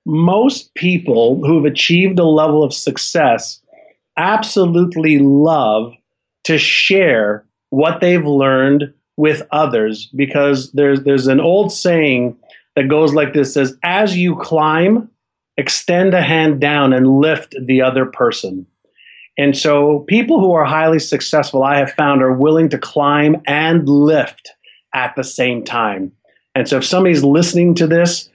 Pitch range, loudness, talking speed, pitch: 140-170 Hz, -13 LUFS, 140 wpm, 150 Hz